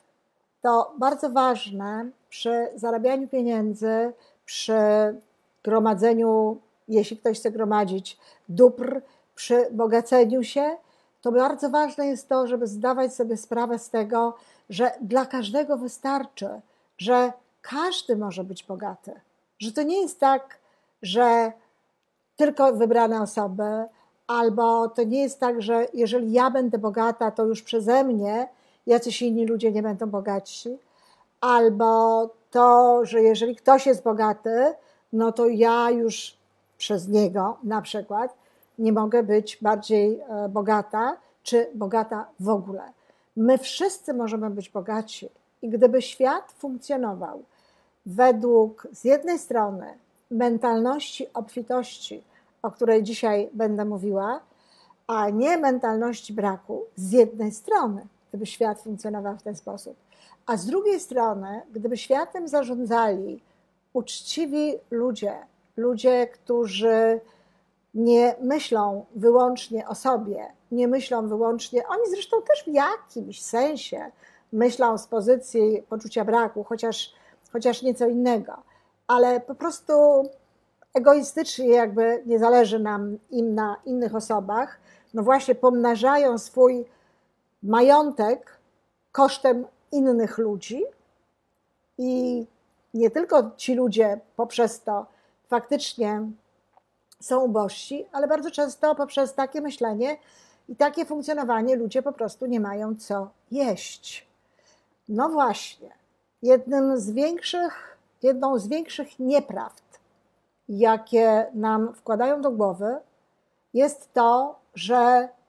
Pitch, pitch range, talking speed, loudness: 235 Hz, 220-260 Hz, 115 wpm, -23 LUFS